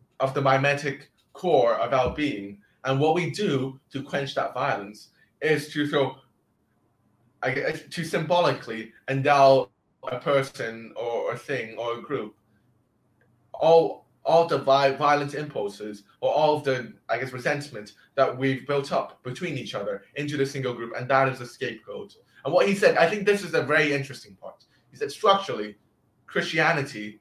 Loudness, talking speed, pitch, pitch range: -25 LUFS, 160 wpm, 135 Hz, 120-150 Hz